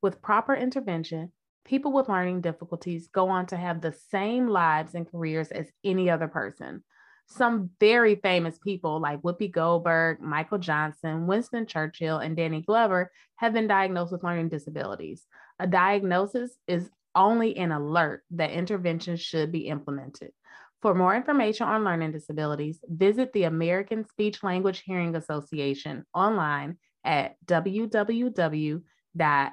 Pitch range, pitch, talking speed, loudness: 160-205 Hz, 175 Hz, 135 wpm, -27 LUFS